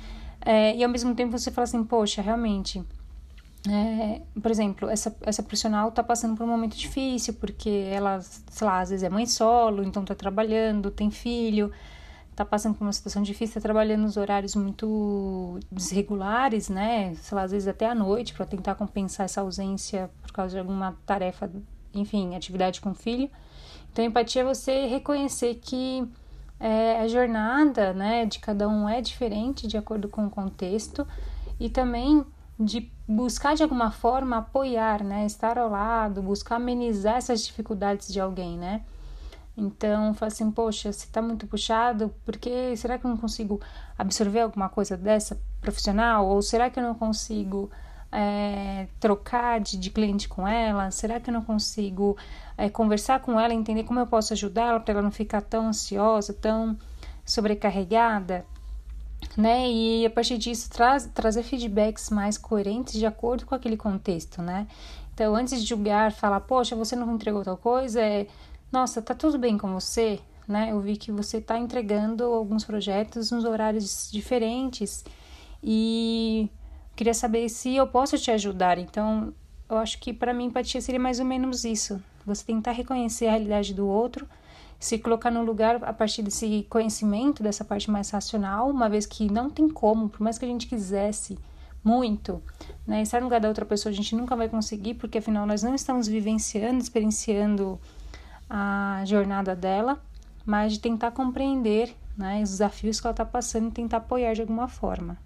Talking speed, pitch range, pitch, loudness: 170 wpm, 205-235 Hz, 220 Hz, -26 LUFS